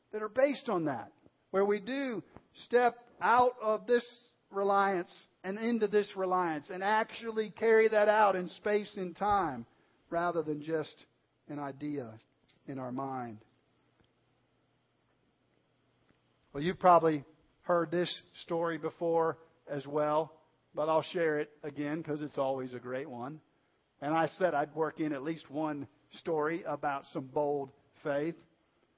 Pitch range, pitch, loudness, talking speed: 145-195 Hz, 160 Hz, -32 LUFS, 140 wpm